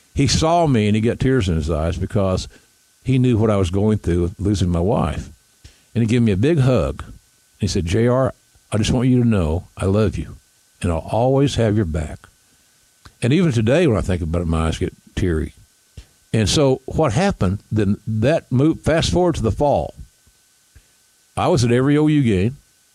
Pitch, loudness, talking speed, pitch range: 110 Hz, -19 LUFS, 200 wpm, 95-130 Hz